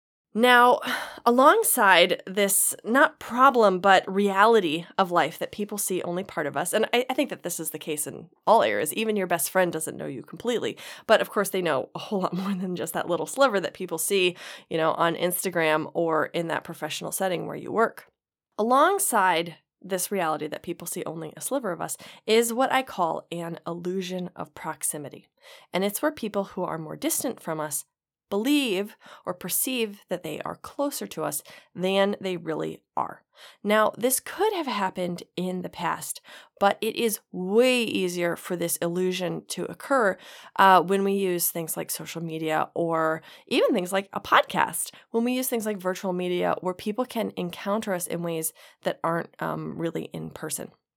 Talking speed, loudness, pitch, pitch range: 185 wpm, -25 LUFS, 185 Hz, 170-220 Hz